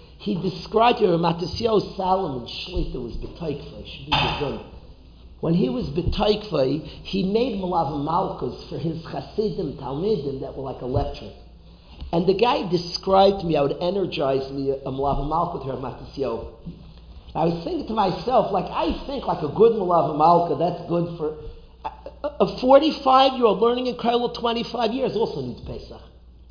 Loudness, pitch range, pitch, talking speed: -23 LUFS, 140-220 Hz, 180 Hz, 145 wpm